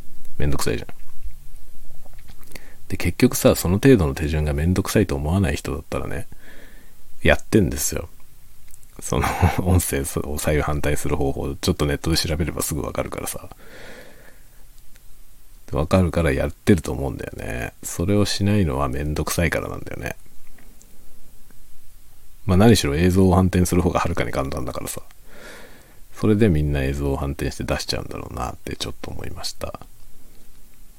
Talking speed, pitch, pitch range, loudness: 335 characters per minute, 85 Hz, 75-100 Hz, -22 LUFS